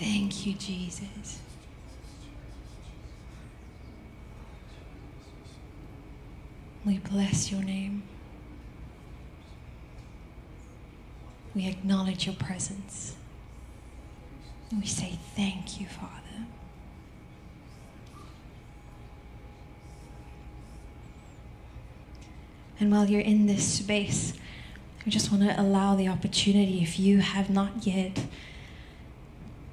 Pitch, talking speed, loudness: 190 Hz, 70 wpm, -28 LUFS